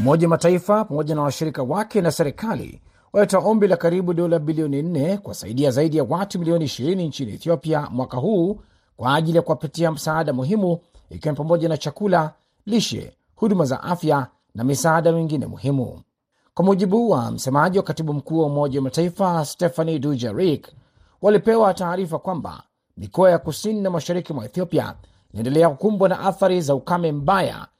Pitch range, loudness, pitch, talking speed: 145-185 Hz, -21 LUFS, 165 Hz, 160 wpm